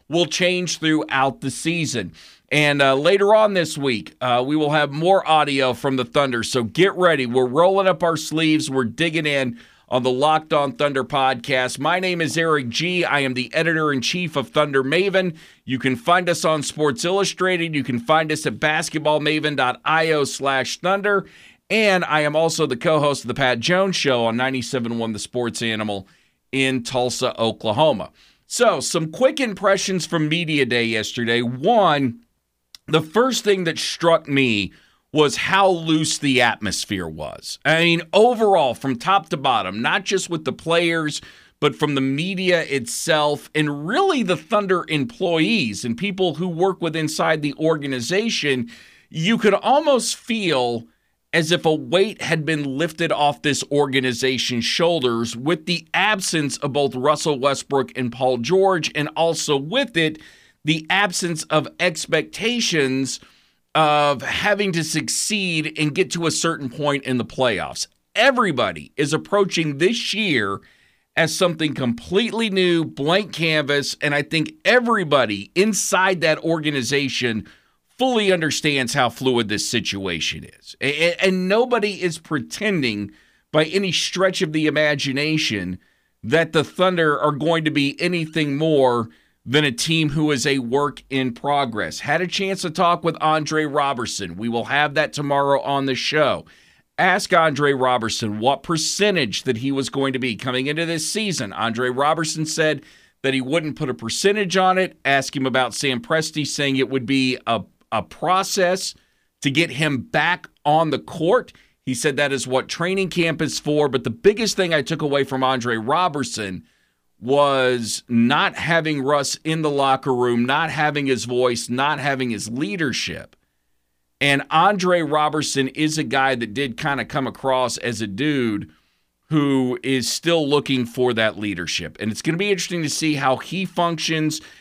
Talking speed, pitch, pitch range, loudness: 160 wpm, 150 Hz, 130-170 Hz, -20 LUFS